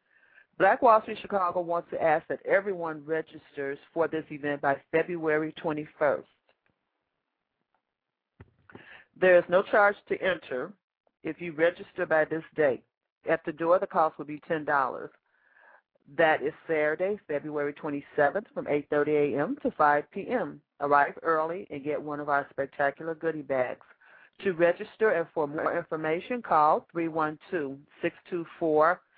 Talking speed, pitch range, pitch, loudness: 135 wpm, 150-175 Hz, 160 Hz, -28 LUFS